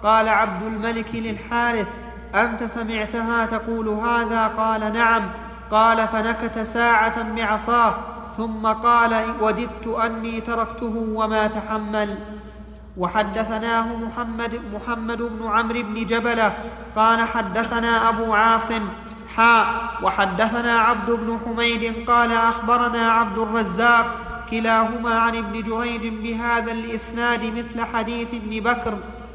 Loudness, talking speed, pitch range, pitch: -21 LUFS, 105 wpm, 225-235 Hz, 230 Hz